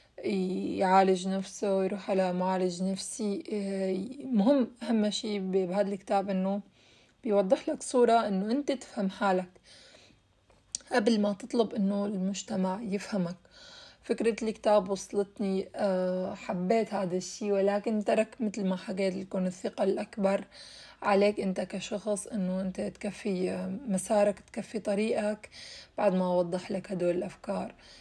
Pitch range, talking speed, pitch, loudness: 190-210 Hz, 115 wpm, 200 Hz, -30 LUFS